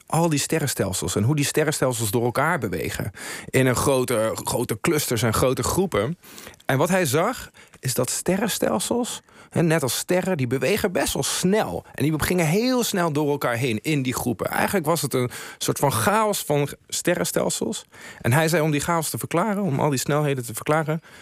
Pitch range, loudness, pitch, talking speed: 130-170 Hz, -23 LUFS, 150 Hz, 190 wpm